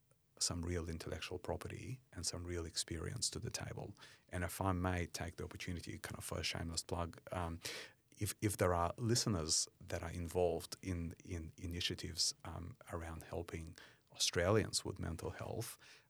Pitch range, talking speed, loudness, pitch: 85-110 Hz, 160 wpm, -41 LUFS, 90 Hz